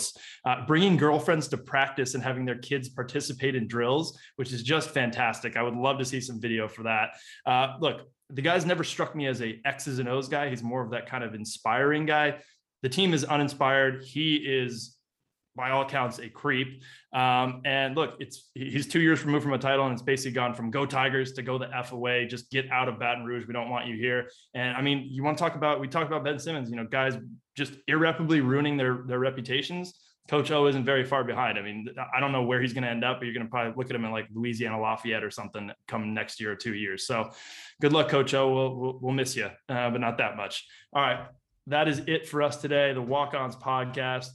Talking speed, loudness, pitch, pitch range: 240 wpm, -28 LUFS, 130 Hz, 120-145 Hz